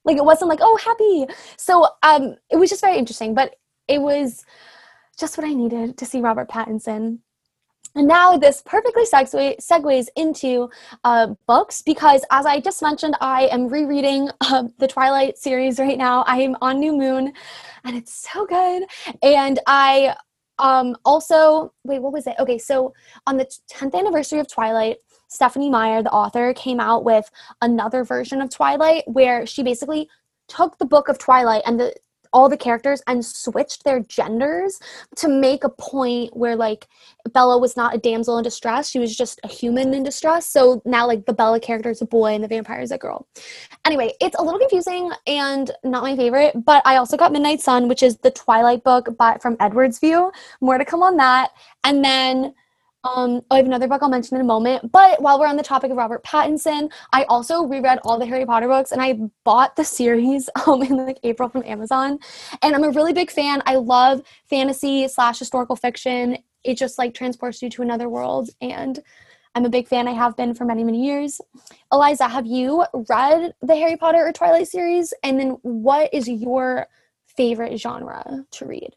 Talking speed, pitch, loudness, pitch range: 195 wpm, 265 Hz, -18 LUFS, 245-295 Hz